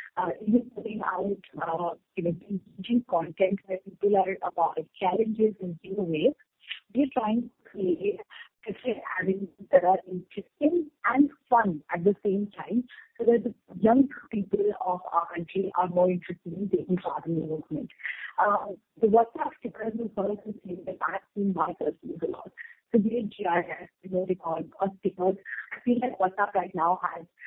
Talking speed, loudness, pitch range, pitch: 175 wpm, -28 LUFS, 180-230 Hz, 195 Hz